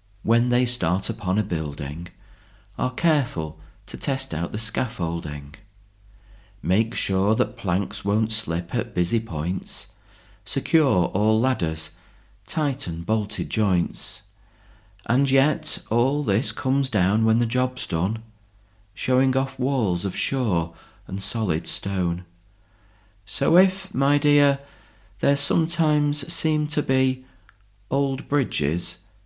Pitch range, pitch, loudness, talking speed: 95-130 Hz, 105 Hz, -24 LUFS, 115 wpm